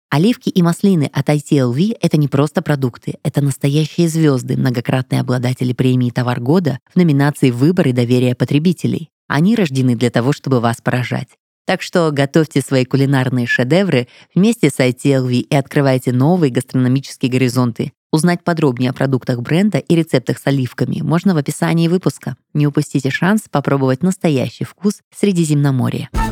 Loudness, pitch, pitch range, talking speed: -16 LUFS, 140 Hz, 130-165 Hz, 145 wpm